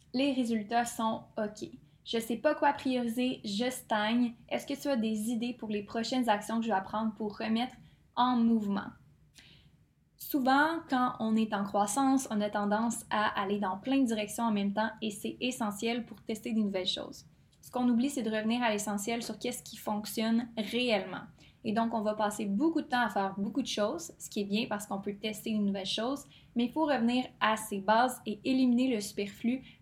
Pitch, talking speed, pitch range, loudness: 225 Hz, 210 wpm, 210-245 Hz, -32 LUFS